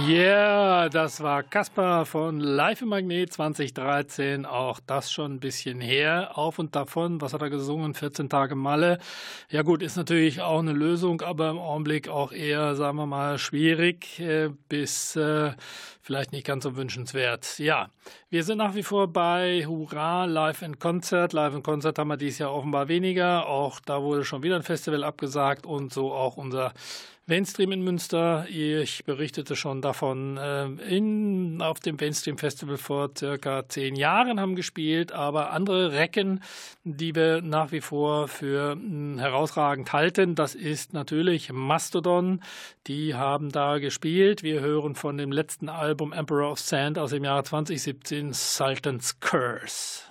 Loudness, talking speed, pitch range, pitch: -26 LUFS, 160 wpm, 145-170 Hz, 150 Hz